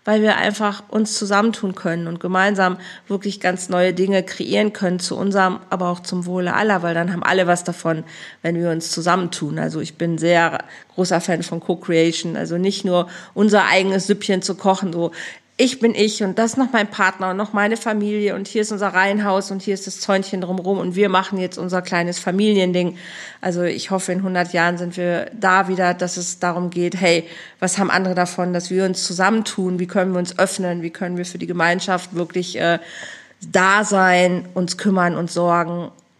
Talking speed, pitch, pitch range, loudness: 200 wpm, 185 Hz, 175-195 Hz, -19 LUFS